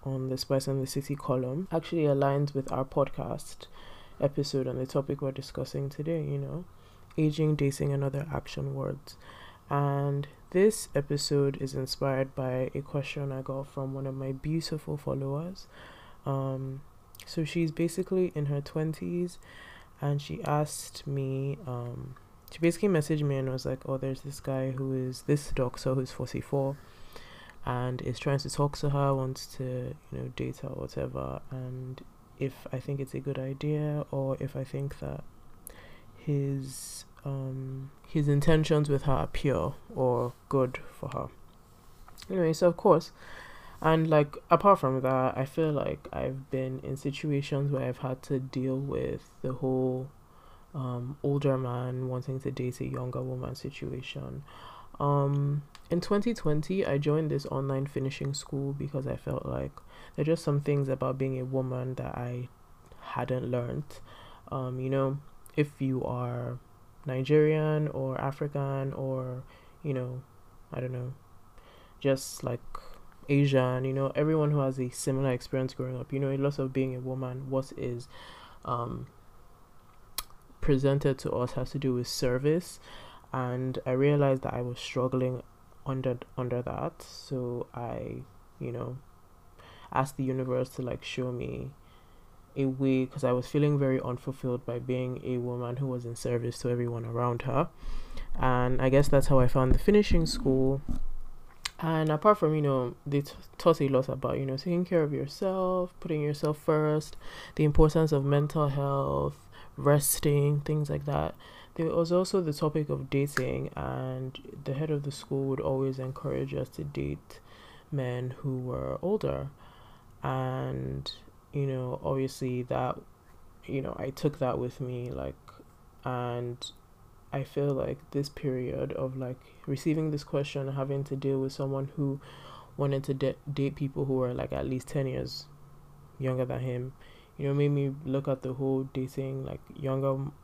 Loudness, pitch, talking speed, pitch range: -31 LUFS, 135 Hz, 160 wpm, 125-145 Hz